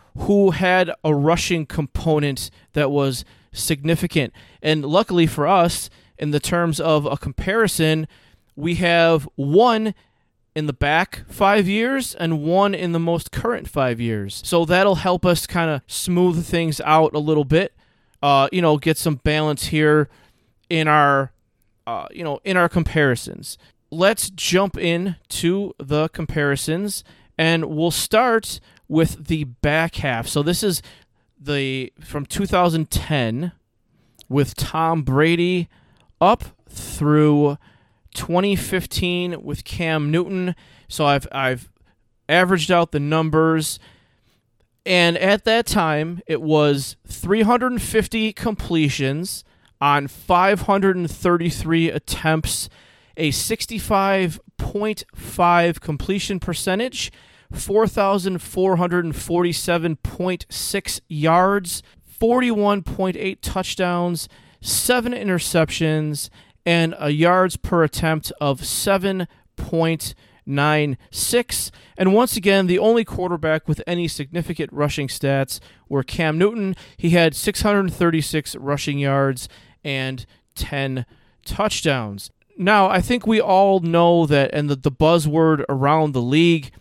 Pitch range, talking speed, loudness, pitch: 140-180 Hz, 110 wpm, -20 LUFS, 160 Hz